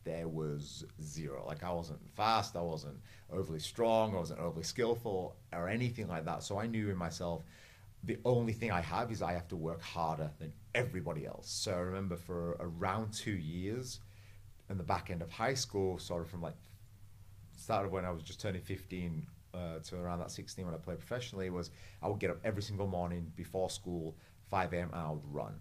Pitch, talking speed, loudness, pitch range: 90 Hz, 205 wpm, -39 LUFS, 85-105 Hz